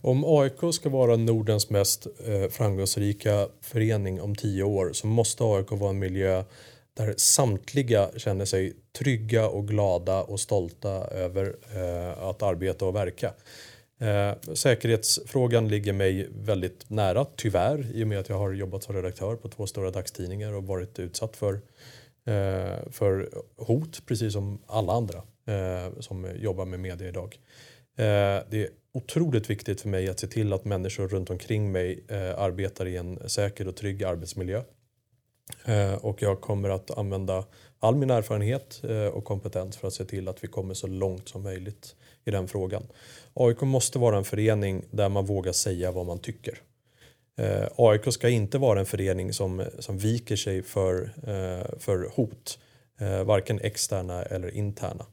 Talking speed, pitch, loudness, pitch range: 150 wpm, 105 Hz, -28 LUFS, 95-115 Hz